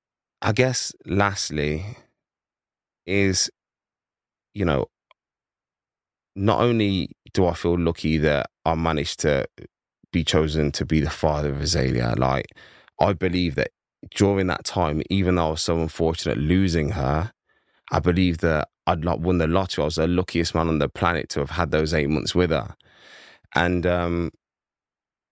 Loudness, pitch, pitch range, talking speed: -23 LUFS, 85 Hz, 75-90 Hz, 150 wpm